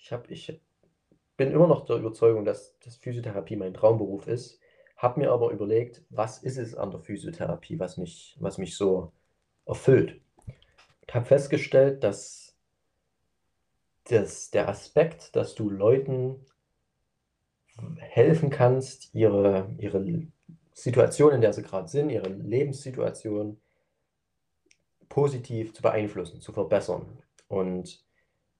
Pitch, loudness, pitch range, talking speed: 120 Hz, -26 LUFS, 100-140 Hz, 120 wpm